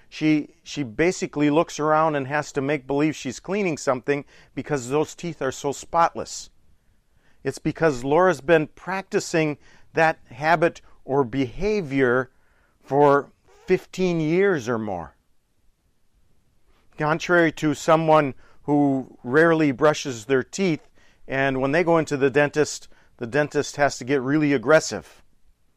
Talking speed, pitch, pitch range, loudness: 130 wpm, 150 Hz, 135-160 Hz, -22 LUFS